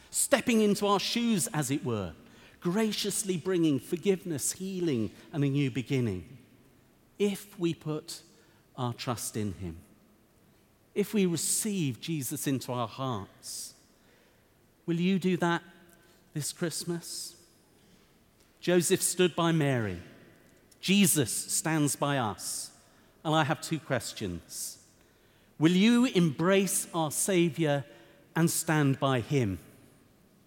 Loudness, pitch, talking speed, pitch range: -29 LUFS, 155 Hz, 110 wpm, 125-180 Hz